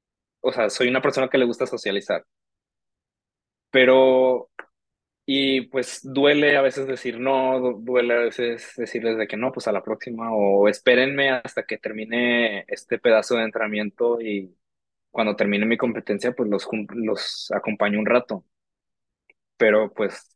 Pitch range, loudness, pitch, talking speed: 110-130 Hz, -22 LUFS, 120 Hz, 145 wpm